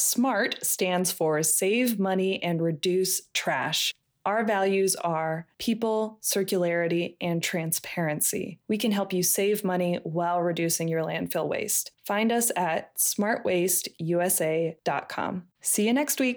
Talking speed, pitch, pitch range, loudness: 125 wpm, 180 Hz, 170-205 Hz, -26 LUFS